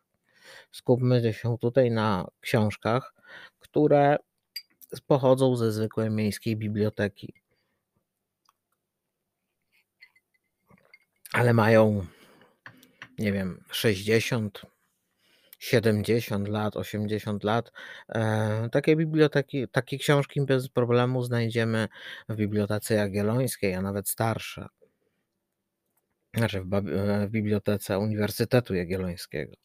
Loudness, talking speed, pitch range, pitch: -26 LUFS, 75 wpm, 105-125 Hz, 110 Hz